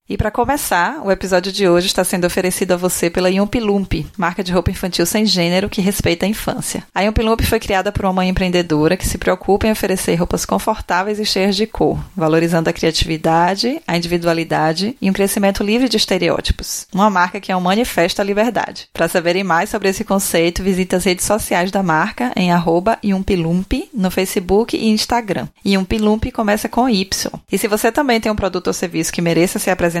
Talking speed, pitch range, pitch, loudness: 195 wpm, 175-215 Hz, 195 Hz, -16 LUFS